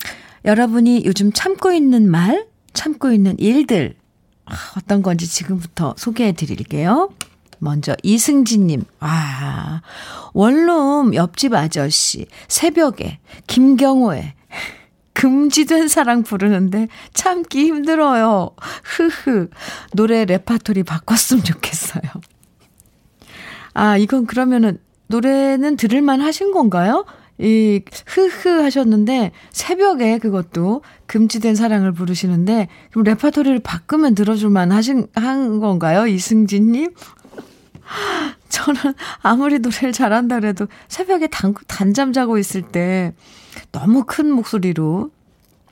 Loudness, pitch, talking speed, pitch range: -16 LUFS, 225 Hz, 240 characters per minute, 190-275 Hz